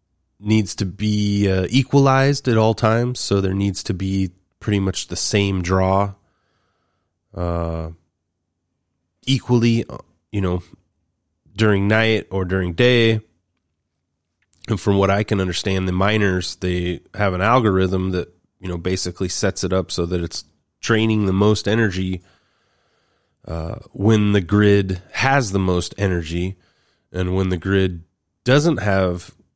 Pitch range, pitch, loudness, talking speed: 90-105 Hz, 95 Hz, -19 LUFS, 135 wpm